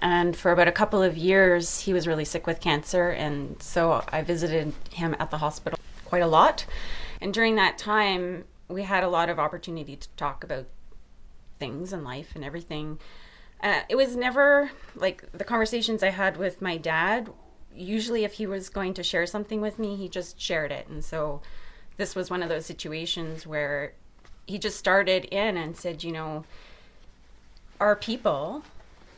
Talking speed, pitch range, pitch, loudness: 180 wpm, 160-200 Hz, 175 Hz, -26 LUFS